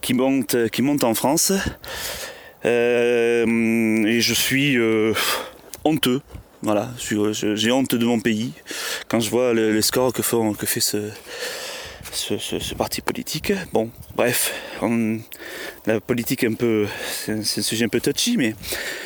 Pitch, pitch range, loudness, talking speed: 115 Hz, 110-125 Hz, -21 LUFS, 165 wpm